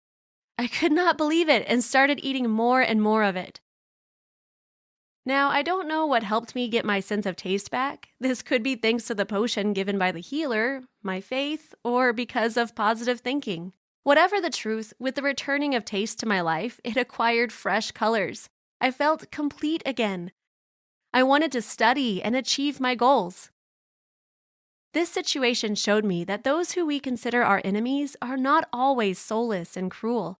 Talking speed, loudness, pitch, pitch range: 175 wpm, -25 LUFS, 240 Hz, 210-275 Hz